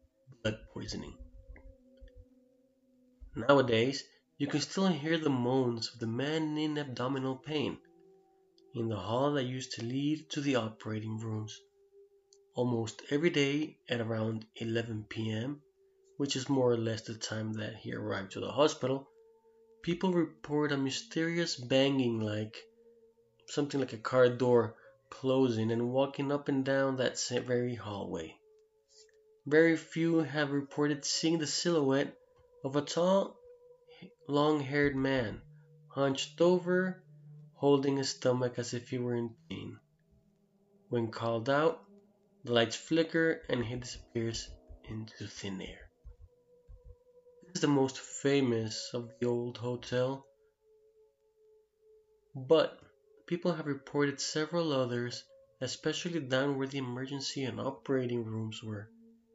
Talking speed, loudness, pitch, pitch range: 125 wpm, -33 LUFS, 140 Hz, 120-175 Hz